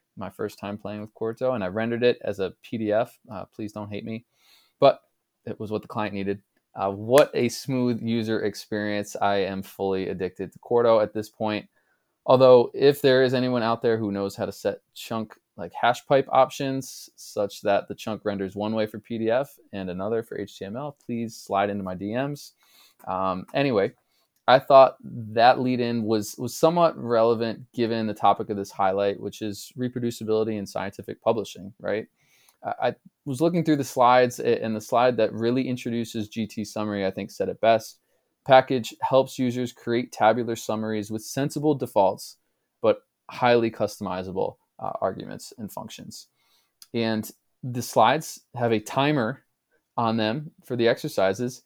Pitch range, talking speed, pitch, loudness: 105-125 Hz, 170 wpm, 115 Hz, -24 LUFS